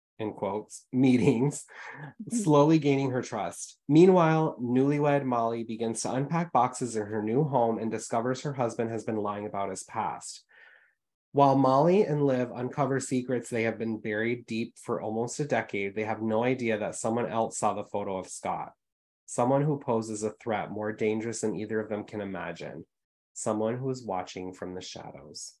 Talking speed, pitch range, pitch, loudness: 175 wpm, 110-135 Hz, 115 Hz, -28 LUFS